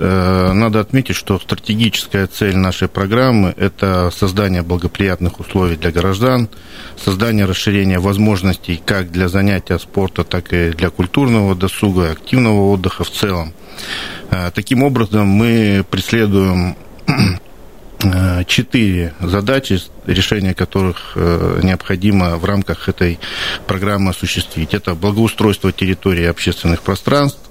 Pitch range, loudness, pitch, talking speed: 90-105 Hz, -15 LUFS, 95 Hz, 105 wpm